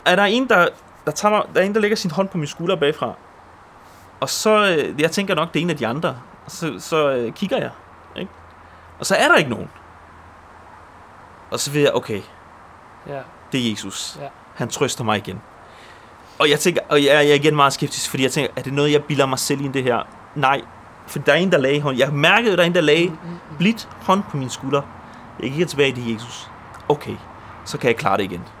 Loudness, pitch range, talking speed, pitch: -19 LUFS, 115-170 Hz, 225 wpm, 145 Hz